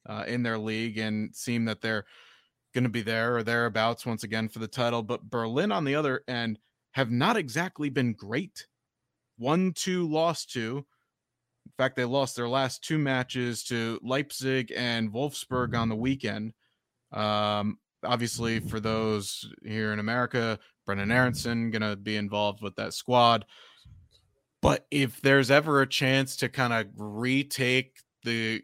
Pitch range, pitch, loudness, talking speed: 110-135 Hz, 120 Hz, -28 LUFS, 160 wpm